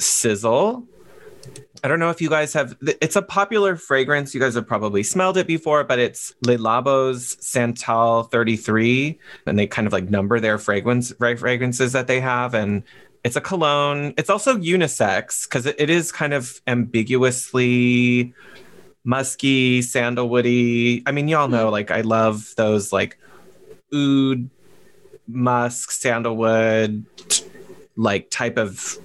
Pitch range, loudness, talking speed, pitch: 115-145 Hz, -20 LUFS, 140 wpm, 125 Hz